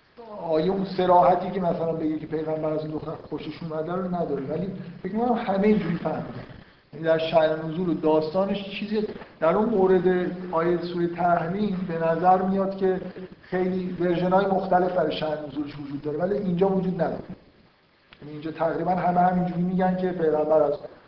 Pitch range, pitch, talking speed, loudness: 155-185 Hz, 175 Hz, 165 wpm, -25 LUFS